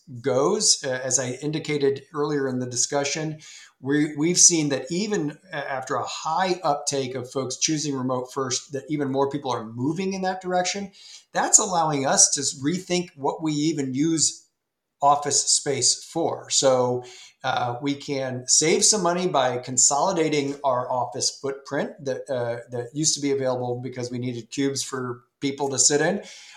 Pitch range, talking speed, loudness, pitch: 130-155 Hz, 165 wpm, -23 LUFS, 140 Hz